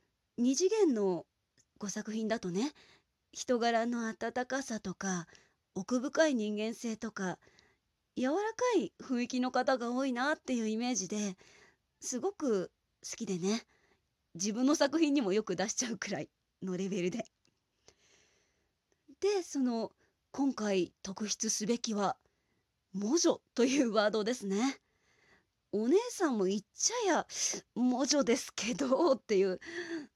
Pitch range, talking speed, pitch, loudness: 200-270 Hz, 240 characters per minute, 230 Hz, -33 LUFS